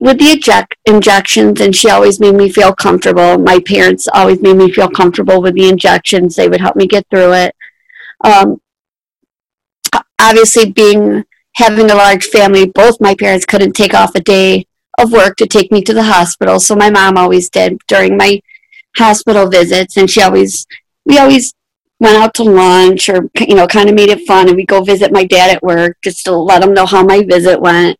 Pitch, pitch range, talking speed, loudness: 195 Hz, 185-210 Hz, 200 wpm, -7 LUFS